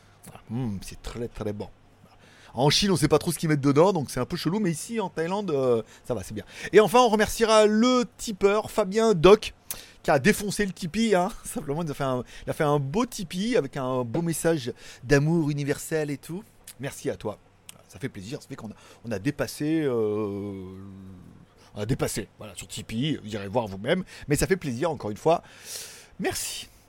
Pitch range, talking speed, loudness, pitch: 110-180 Hz, 210 wpm, -25 LUFS, 145 Hz